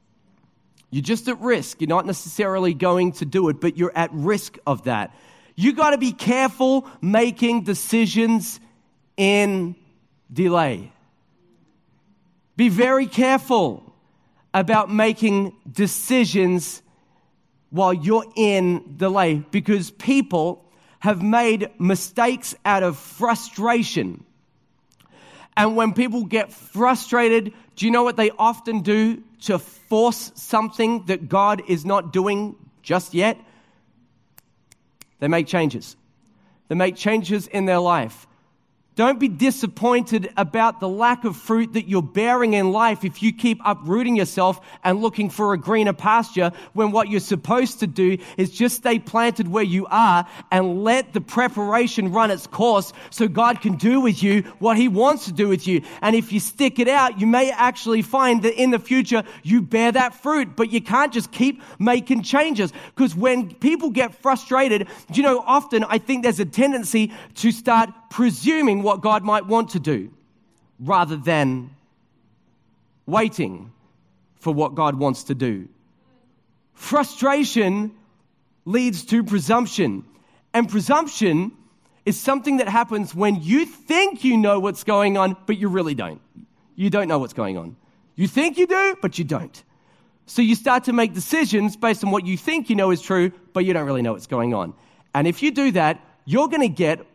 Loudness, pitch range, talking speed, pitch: -20 LUFS, 185-235 Hz, 160 wpm, 210 Hz